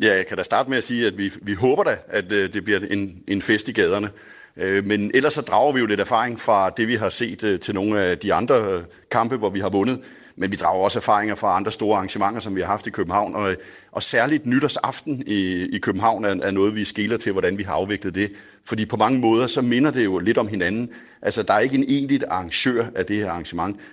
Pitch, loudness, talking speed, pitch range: 105 Hz, -21 LUFS, 250 wpm, 100-115 Hz